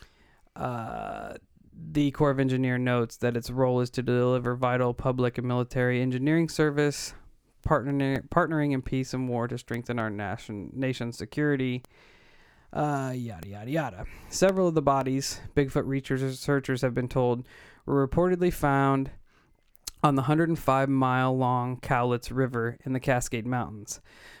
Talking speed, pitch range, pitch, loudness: 140 wpm, 125-140 Hz, 130 Hz, -27 LUFS